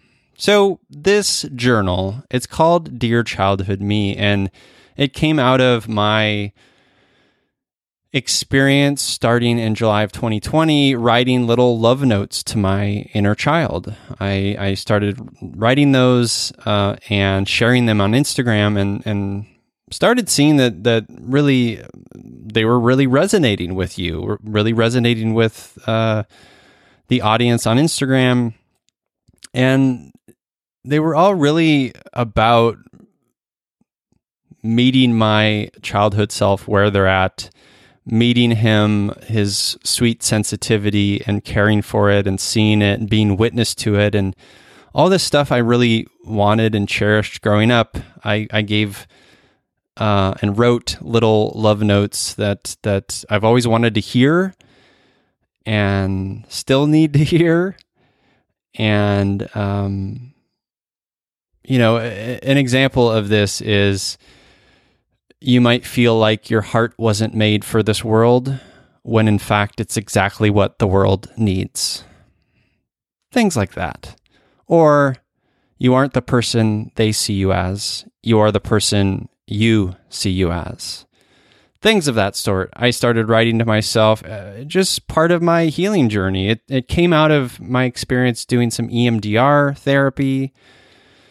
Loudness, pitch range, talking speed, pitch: -16 LUFS, 105-125 Hz, 130 wpm, 115 Hz